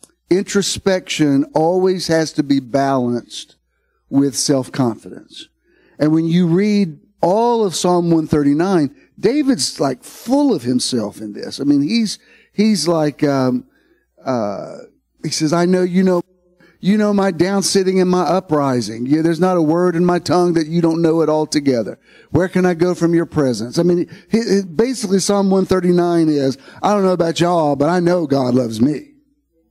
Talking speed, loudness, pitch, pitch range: 170 wpm, -16 LUFS, 170 Hz, 150-190 Hz